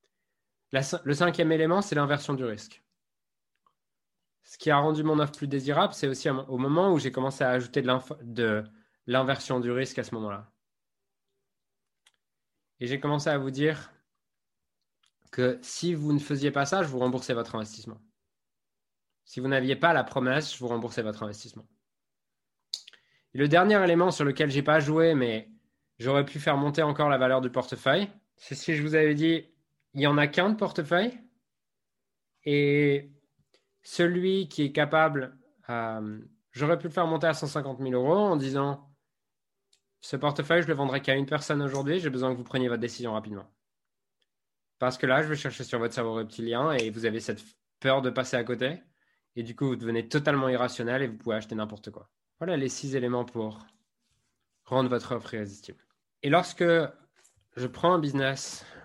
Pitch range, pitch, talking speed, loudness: 120-155 Hz, 140 Hz, 180 wpm, -27 LUFS